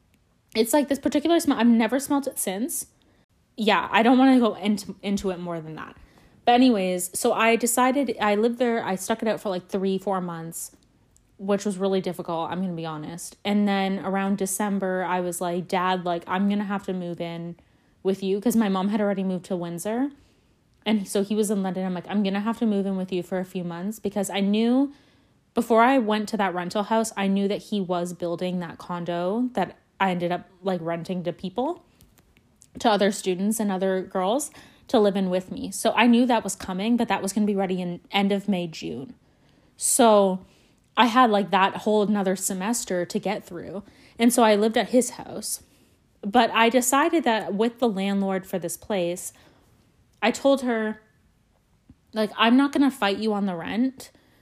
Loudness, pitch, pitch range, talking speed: -24 LUFS, 200 Hz, 185-225 Hz, 210 wpm